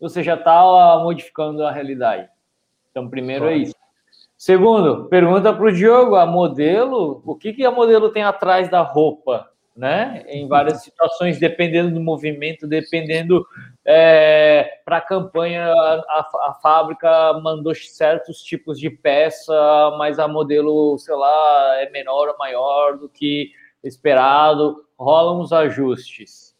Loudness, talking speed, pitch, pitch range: -16 LUFS, 135 wpm, 160 Hz, 150-175 Hz